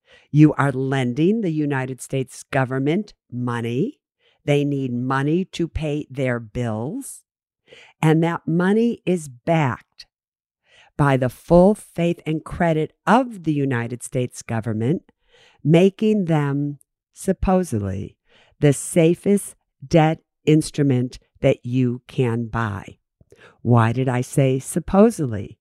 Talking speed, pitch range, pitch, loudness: 110 wpm, 125-175 Hz, 145 Hz, -21 LUFS